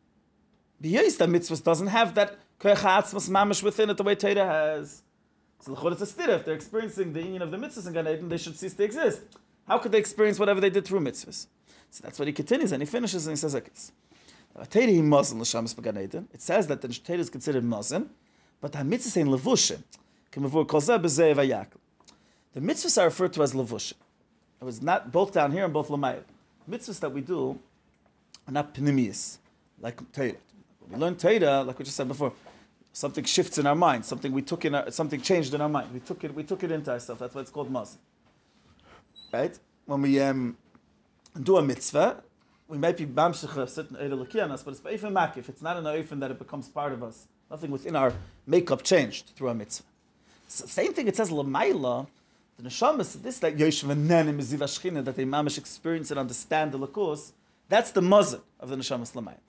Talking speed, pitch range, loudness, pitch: 180 wpm, 135-185 Hz, -26 LUFS, 155 Hz